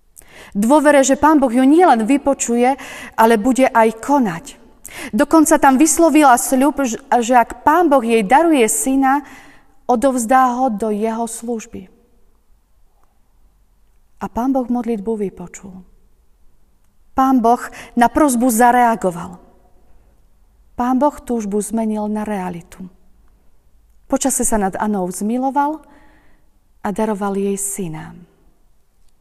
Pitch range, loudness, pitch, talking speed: 210-270 Hz, -15 LUFS, 240 Hz, 105 wpm